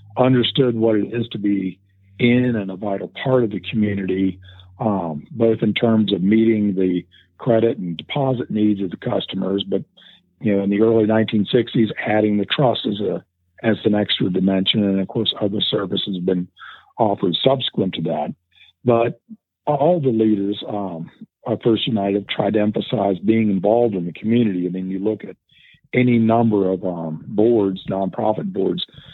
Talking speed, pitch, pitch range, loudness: 170 wpm, 105 Hz, 95-115 Hz, -20 LUFS